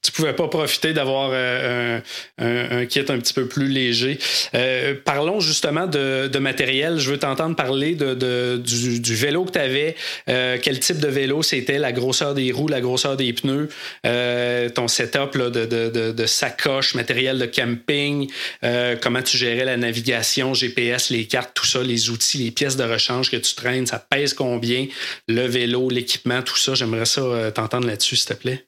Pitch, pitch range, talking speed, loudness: 125 Hz, 120-140 Hz, 195 wpm, -20 LUFS